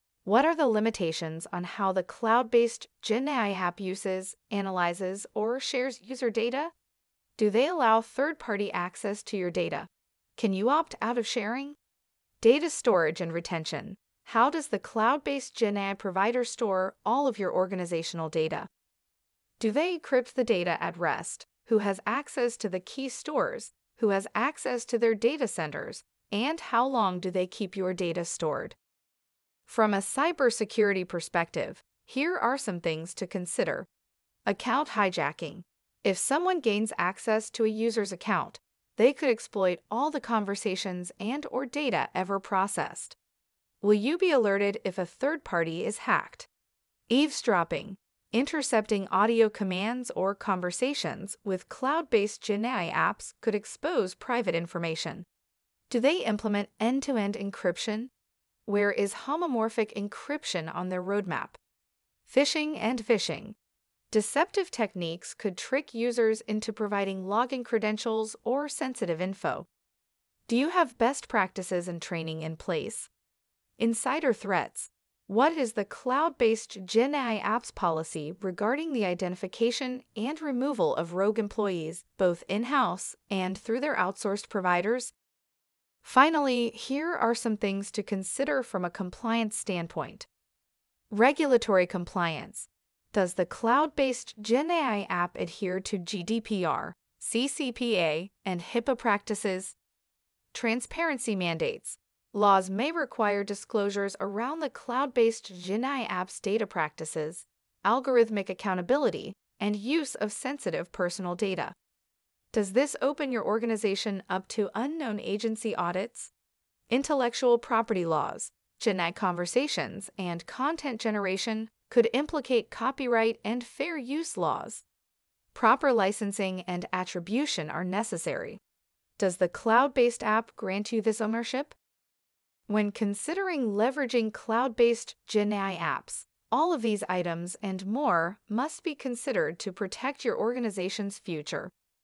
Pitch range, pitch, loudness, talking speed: 190-250 Hz, 215 Hz, -29 LUFS, 125 wpm